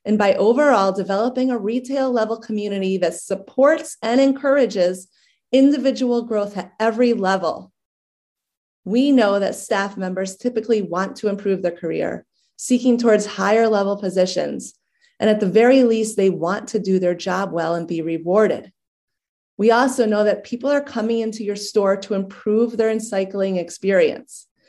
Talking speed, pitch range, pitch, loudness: 155 wpm, 190-235 Hz, 210 Hz, -19 LUFS